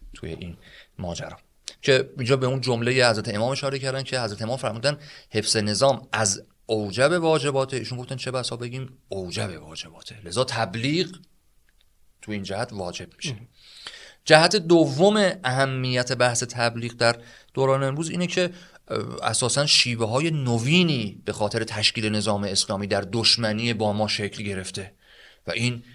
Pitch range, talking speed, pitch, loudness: 110-135 Hz, 145 wpm, 120 Hz, -23 LUFS